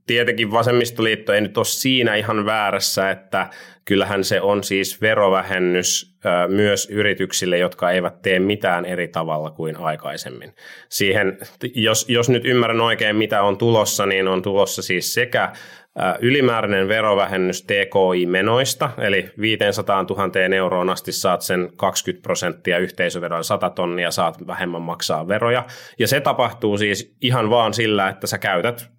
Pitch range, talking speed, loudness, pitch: 95-110 Hz, 140 wpm, -19 LUFS, 100 Hz